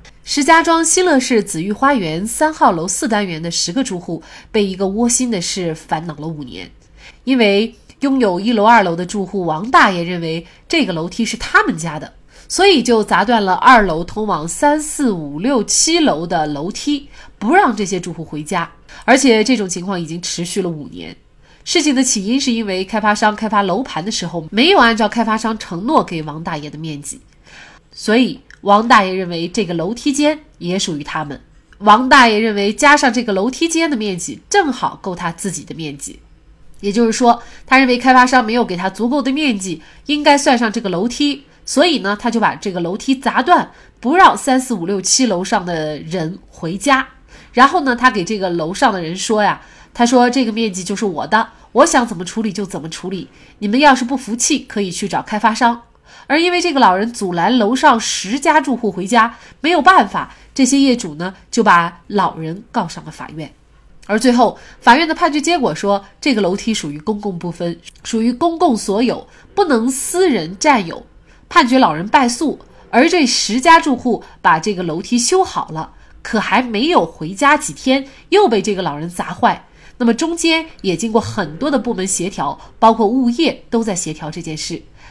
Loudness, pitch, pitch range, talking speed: -15 LUFS, 220 Hz, 185-265 Hz, 285 characters per minute